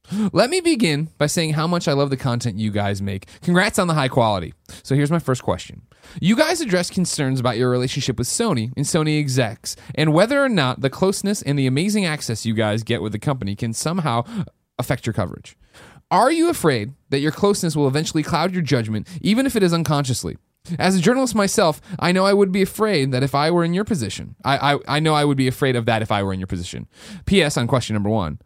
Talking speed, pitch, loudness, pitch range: 235 wpm, 145 Hz, -20 LUFS, 120-180 Hz